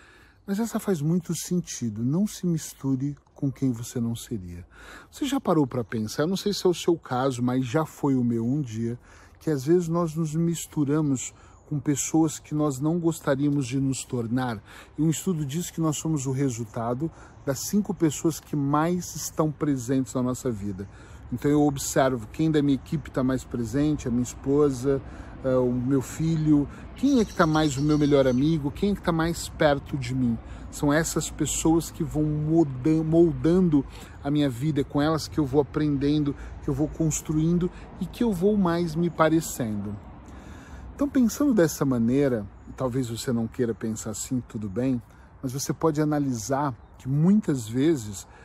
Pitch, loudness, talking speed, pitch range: 145 Hz, -26 LUFS, 180 wpm, 125-160 Hz